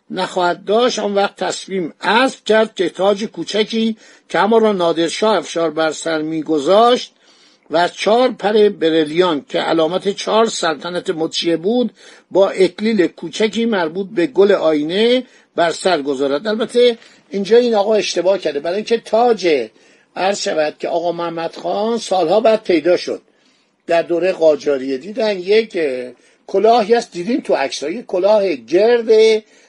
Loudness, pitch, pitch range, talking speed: -16 LUFS, 195 Hz, 170-220 Hz, 140 wpm